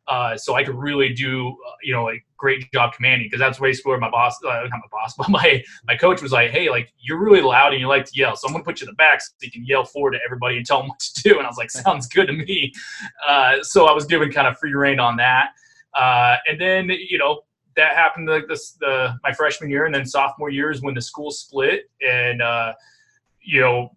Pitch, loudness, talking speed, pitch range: 140 Hz, -18 LUFS, 265 wpm, 125-165 Hz